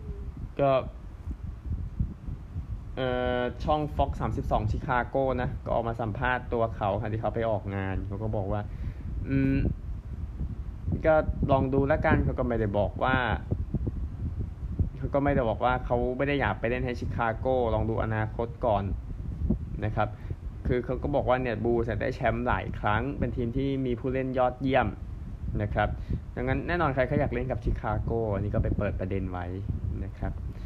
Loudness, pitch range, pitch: -29 LUFS, 95-125 Hz, 110 Hz